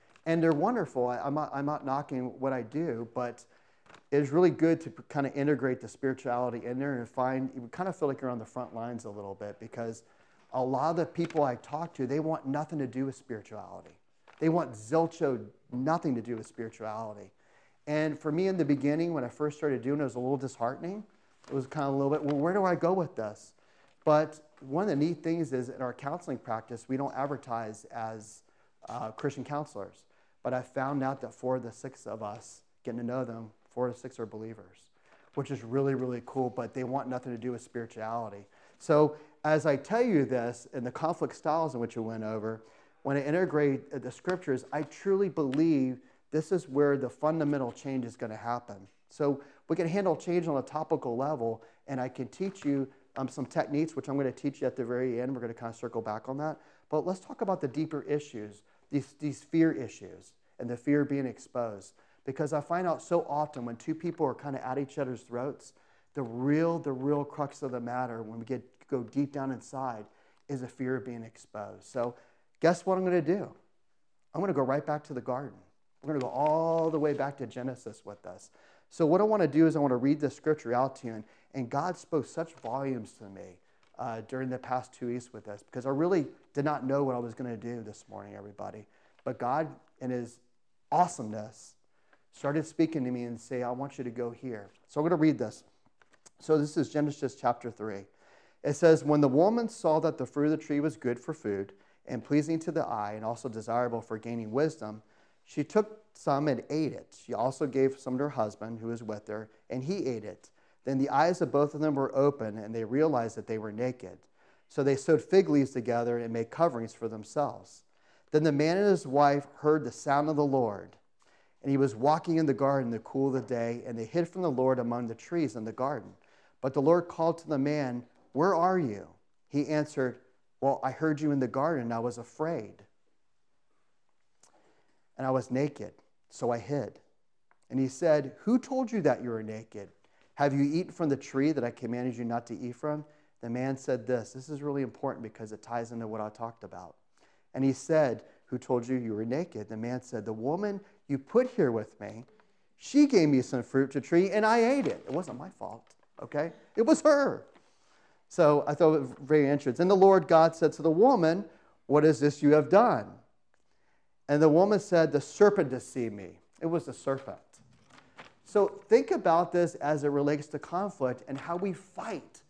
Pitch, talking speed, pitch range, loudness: 135 Hz, 220 wpm, 120-155 Hz, -30 LUFS